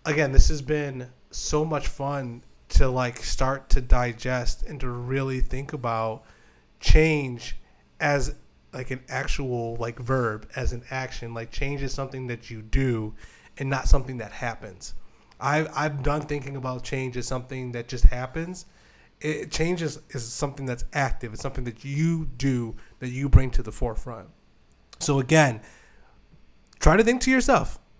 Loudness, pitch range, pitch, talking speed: -26 LUFS, 120-140 Hz, 130 Hz, 165 wpm